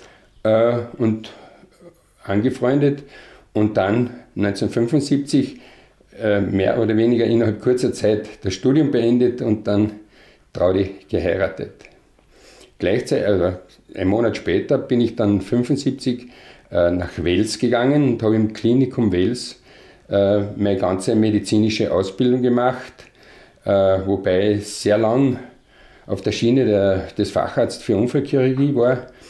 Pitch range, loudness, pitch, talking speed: 100-125 Hz, -19 LUFS, 115 Hz, 115 wpm